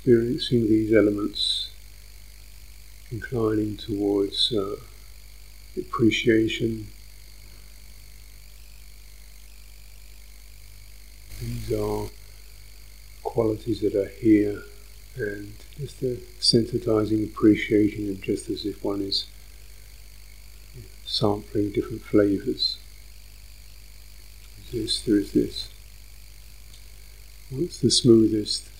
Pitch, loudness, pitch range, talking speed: 105 Hz, -24 LUFS, 100-110 Hz, 75 wpm